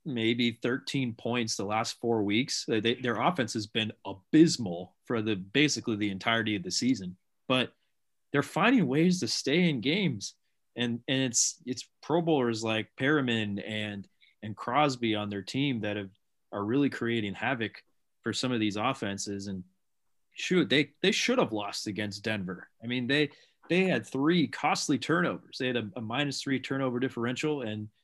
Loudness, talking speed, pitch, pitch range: -29 LUFS, 170 wpm, 120 Hz, 105-135 Hz